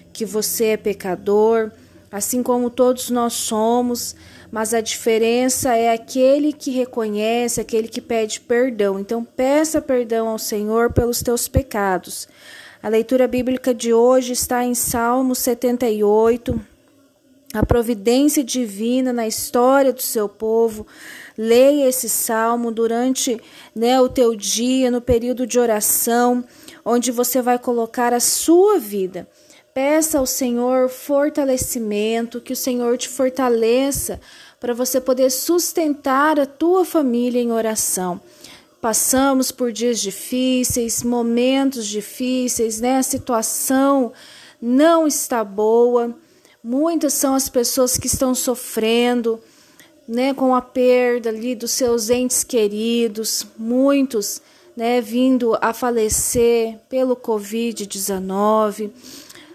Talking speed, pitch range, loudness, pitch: 120 wpm, 230-260 Hz, -18 LUFS, 245 Hz